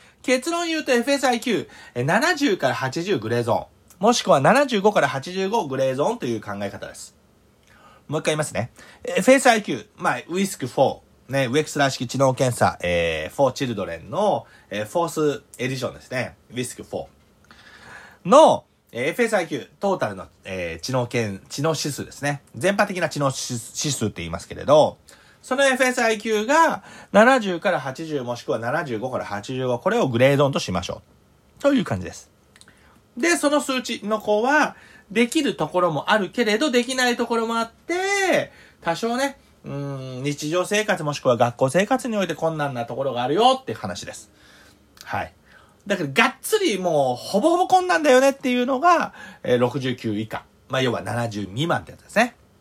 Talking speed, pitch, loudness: 320 characters per minute, 165 Hz, -22 LUFS